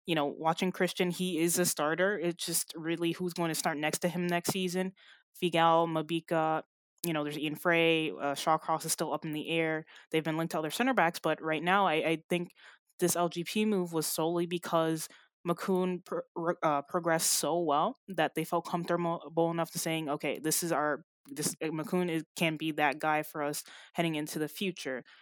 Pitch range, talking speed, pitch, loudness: 155-175 Hz, 200 wpm, 165 Hz, -31 LUFS